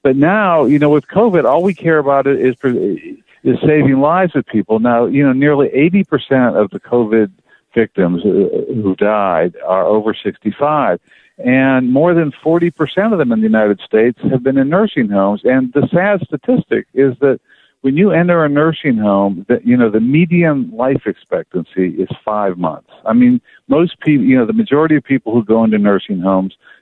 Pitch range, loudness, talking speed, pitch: 120-170 Hz, -13 LUFS, 185 wpm, 140 Hz